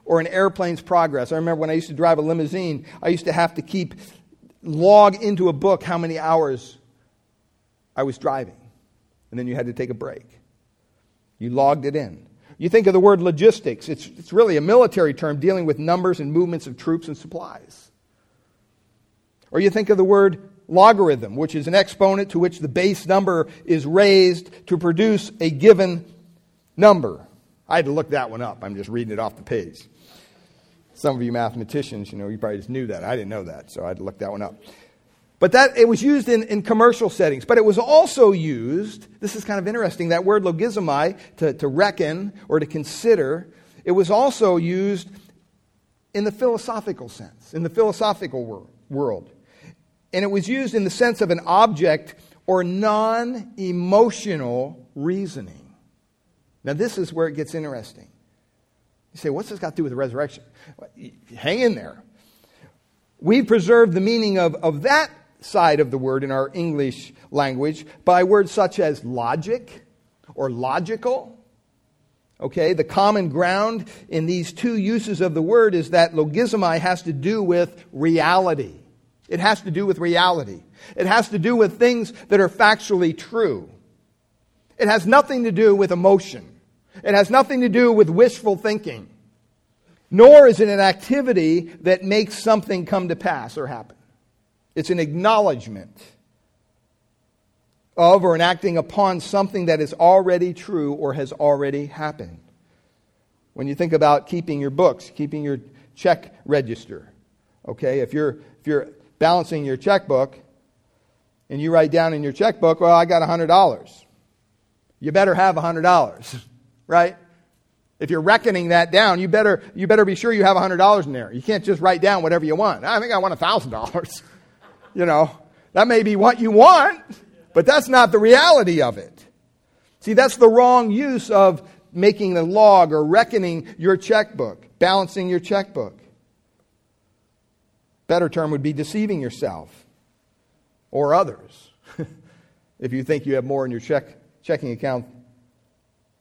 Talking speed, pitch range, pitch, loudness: 170 wpm, 135-200 Hz, 170 Hz, -18 LUFS